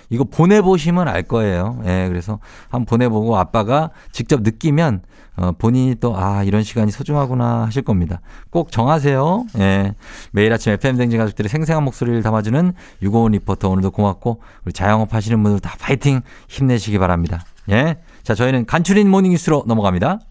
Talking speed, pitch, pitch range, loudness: 385 characters per minute, 115 Hz, 100-140 Hz, -17 LUFS